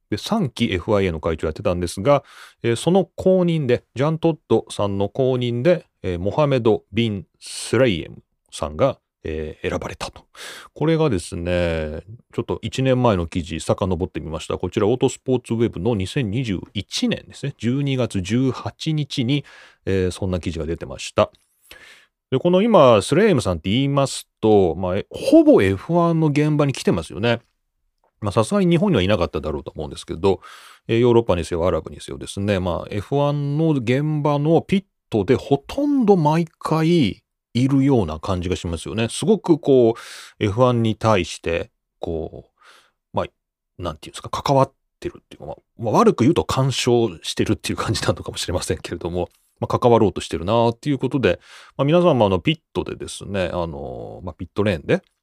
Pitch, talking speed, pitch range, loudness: 120 Hz, 355 characters per minute, 95-150 Hz, -20 LUFS